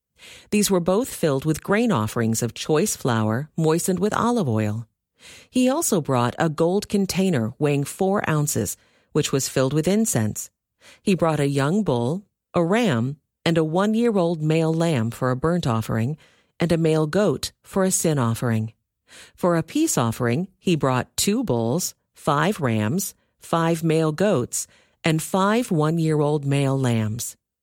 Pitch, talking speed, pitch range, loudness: 155 Hz, 160 wpm, 125-185 Hz, -22 LUFS